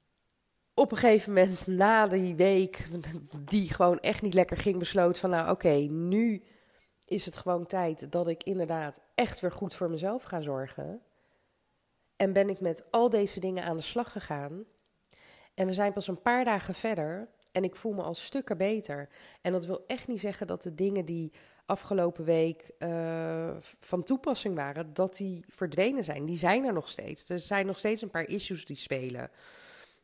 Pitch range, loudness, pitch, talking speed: 170-205 Hz, -30 LUFS, 185 Hz, 185 wpm